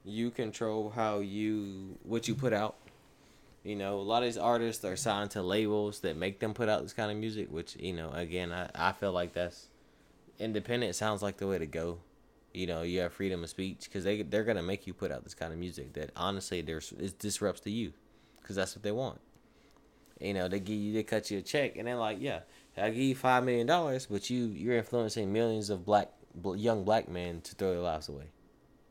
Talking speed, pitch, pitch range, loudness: 230 wpm, 105 Hz, 90-110 Hz, -34 LUFS